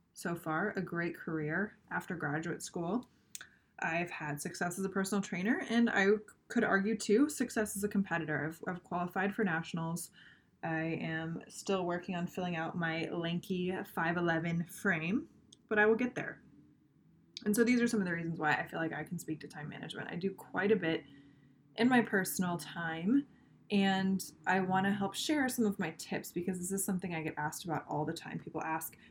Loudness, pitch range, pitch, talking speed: -35 LUFS, 160-205 Hz, 180 Hz, 195 wpm